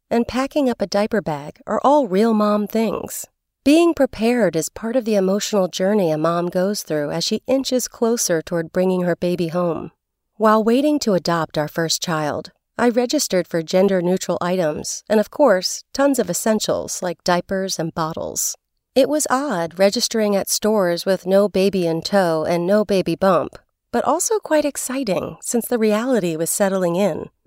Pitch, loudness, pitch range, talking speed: 200 Hz, -19 LUFS, 175-235 Hz, 175 wpm